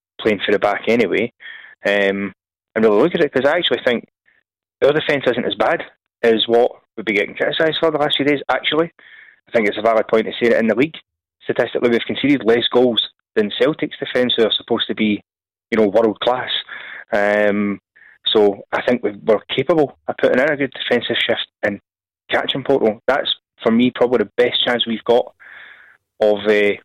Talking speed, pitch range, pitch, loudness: 200 wpm, 105-130 Hz, 115 Hz, -17 LUFS